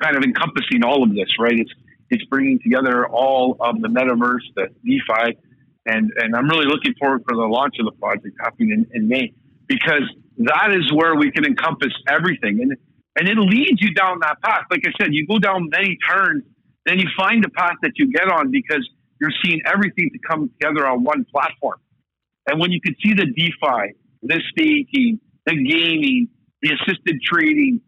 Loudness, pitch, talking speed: -18 LUFS, 195 Hz, 195 wpm